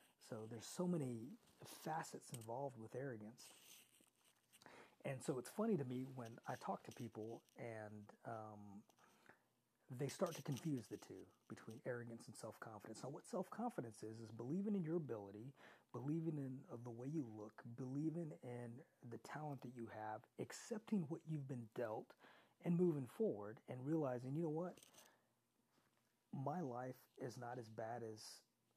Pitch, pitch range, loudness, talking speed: 125 Hz, 115-155 Hz, -49 LUFS, 150 wpm